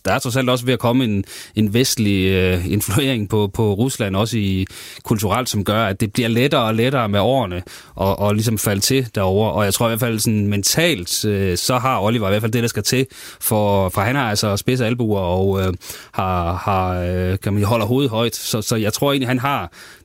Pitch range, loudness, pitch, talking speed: 100-120 Hz, -18 LUFS, 110 Hz, 230 wpm